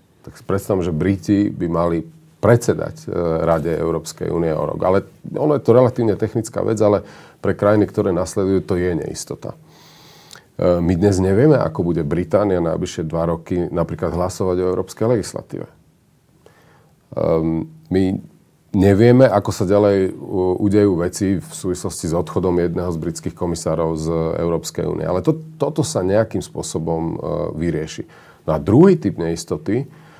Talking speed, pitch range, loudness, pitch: 145 wpm, 85-105 Hz, -19 LUFS, 95 Hz